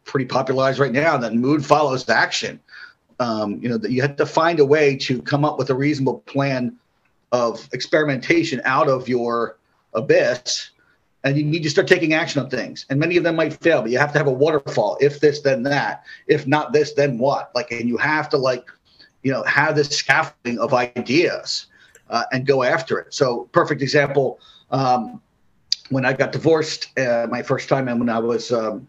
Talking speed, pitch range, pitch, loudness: 205 wpm, 125-150 Hz, 135 Hz, -20 LUFS